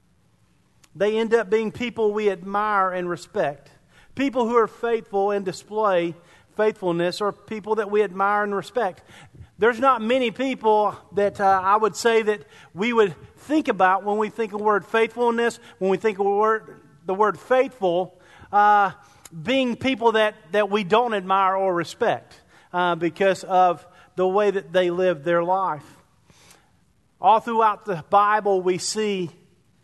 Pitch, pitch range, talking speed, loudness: 205 Hz, 185-220 Hz, 155 wpm, -22 LUFS